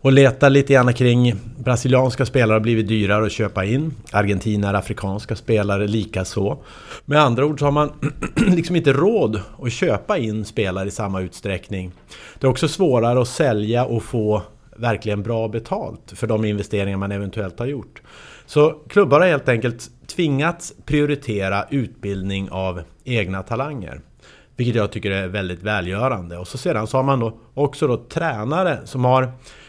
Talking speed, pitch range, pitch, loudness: 160 wpm, 100-135 Hz, 115 Hz, -20 LUFS